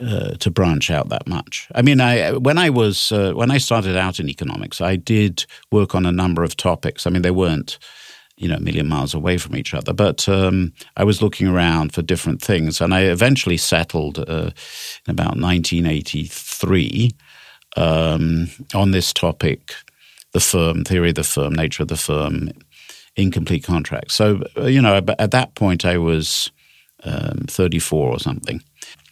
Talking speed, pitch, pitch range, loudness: 175 wpm, 95 Hz, 85-115 Hz, -18 LUFS